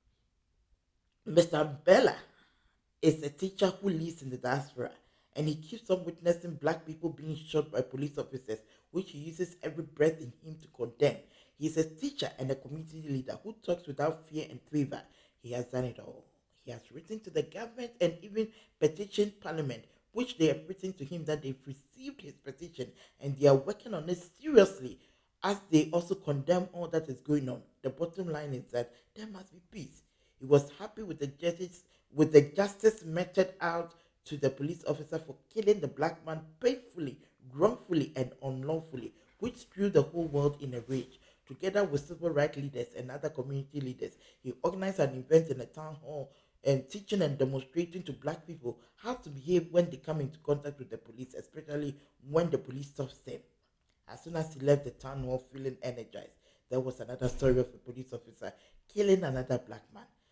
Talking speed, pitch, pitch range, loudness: 190 wpm, 150 Hz, 135-175 Hz, -33 LUFS